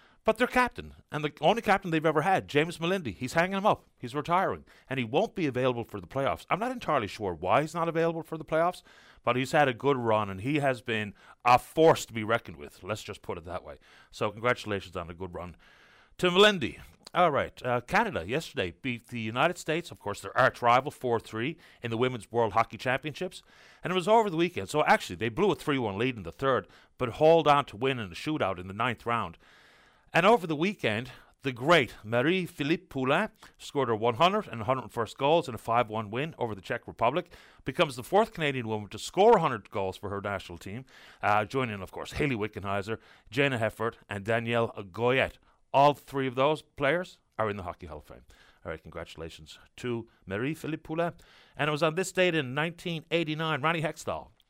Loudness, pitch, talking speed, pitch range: -28 LUFS, 130 Hz, 210 wpm, 110-160 Hz